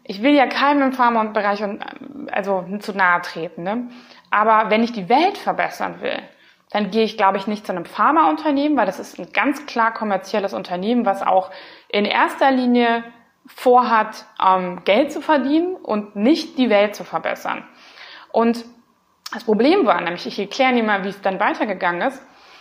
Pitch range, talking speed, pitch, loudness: 200-265 Hz, 175 wpm, 220 Hz, -19 LUFS